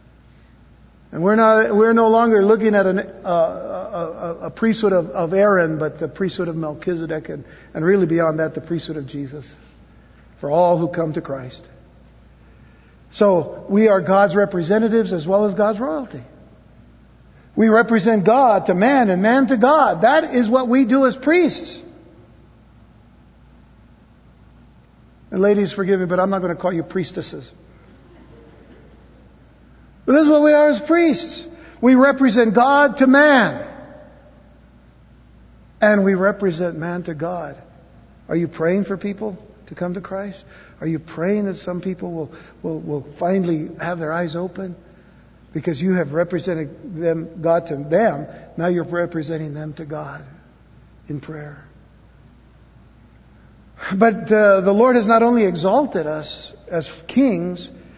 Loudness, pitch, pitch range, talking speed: -18 LUFS, 185 Hz, 165-220 Hz, 150 wpm